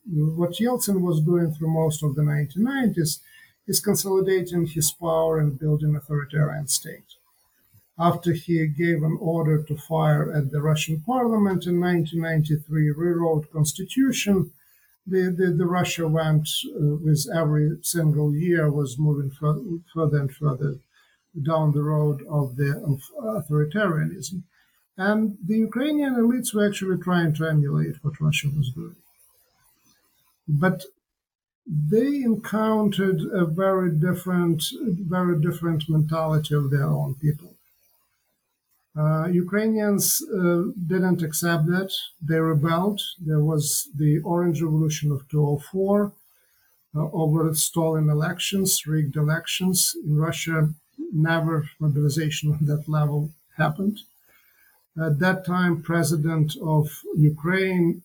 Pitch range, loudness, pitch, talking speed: 150-185 Hz, -23 LUFS, 165 Hz, 120 wpm